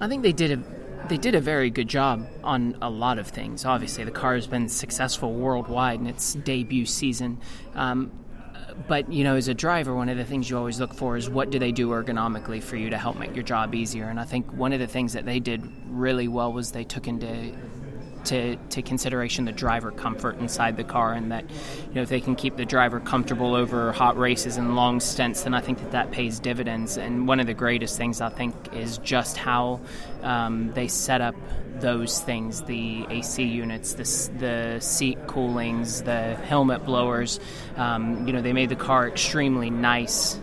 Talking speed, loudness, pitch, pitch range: 210 wpm, -26 LUFS, 125 Hz, 120-130 Hz